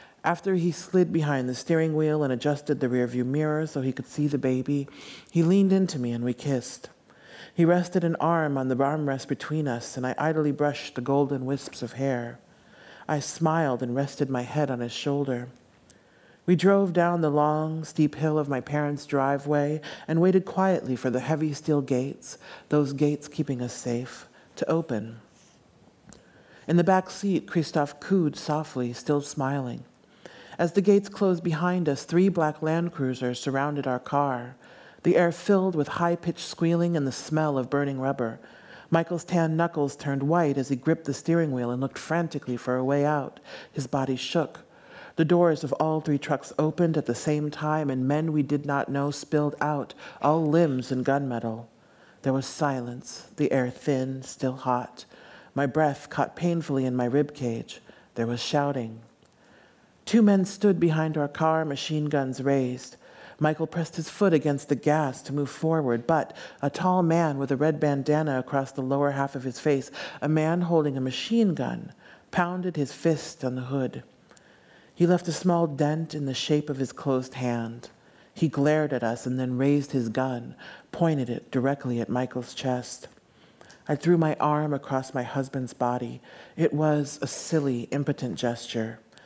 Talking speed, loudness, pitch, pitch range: 175 wpm, -26 LUFS, 145 Hz, 130-160 Hz